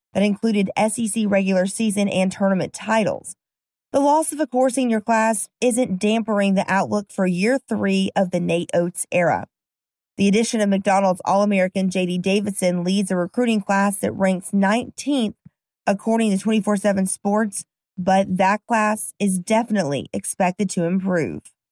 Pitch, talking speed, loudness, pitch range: 200 Hz, 150 wpm, -20 LUFS, 190-220 Hz